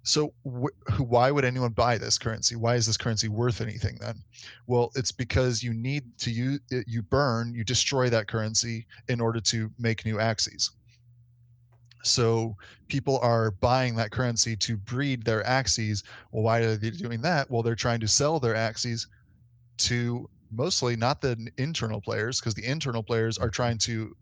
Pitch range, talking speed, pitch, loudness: 115-125 Hz, 175 wpm, 120 Hz, -27 LUFS